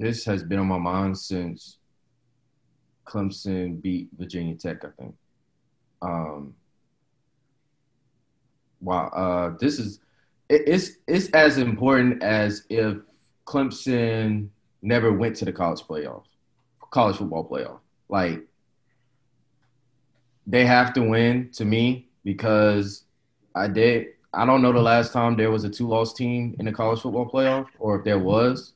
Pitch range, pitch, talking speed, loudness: 100-125 Hz, 115 Hz, 140 wpm, -23 LUFS